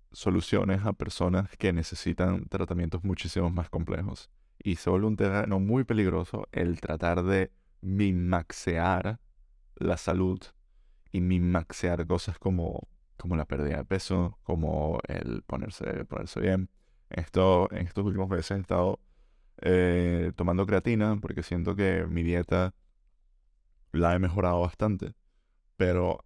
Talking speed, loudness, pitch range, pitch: 125 wpm, -29 LUFS, 85-95 Hz, 90 Hz